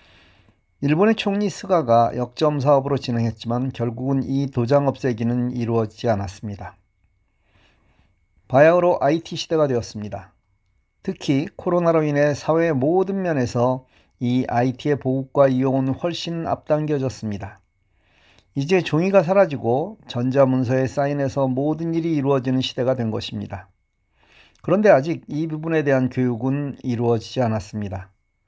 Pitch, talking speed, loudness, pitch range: 130 Hz, 310 characters per minute, -21 LUFS, 105-145 Hz